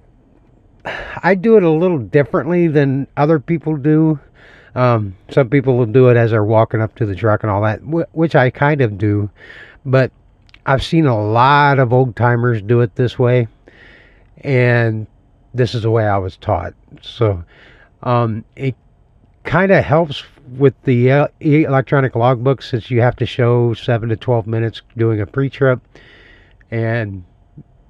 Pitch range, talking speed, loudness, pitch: 110-140 Hz, 160 wpm, -15 LUFS, 120 Hz